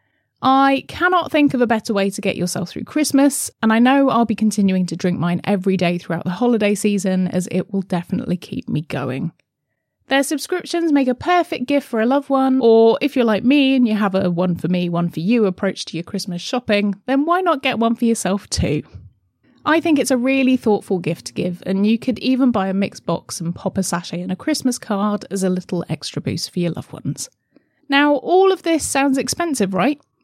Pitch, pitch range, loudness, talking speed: 210 Hz, 180-270 Hz, -18 LUFS, 225 wpm